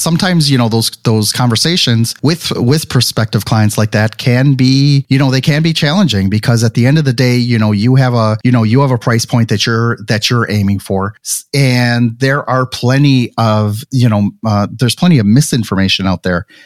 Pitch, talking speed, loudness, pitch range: 120 Hz, 215 wpm, -11 LUFS, 110-135 Hz